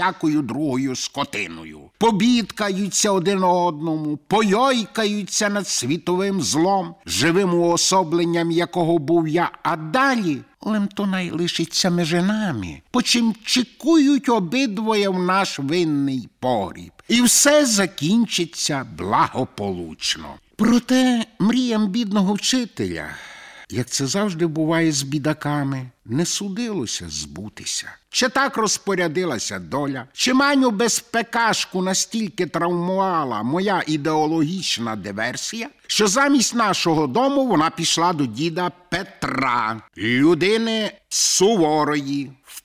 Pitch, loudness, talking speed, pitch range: 180 Hz, -20 LUFS, 100 wpm, 155-220 Hz